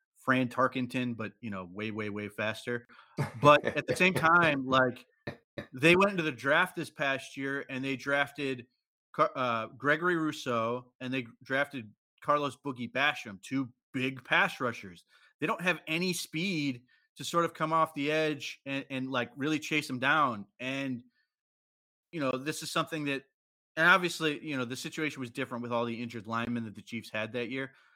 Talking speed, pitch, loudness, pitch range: 180 wpm, 130 Hz, -30 LUFS, 120-150 Hz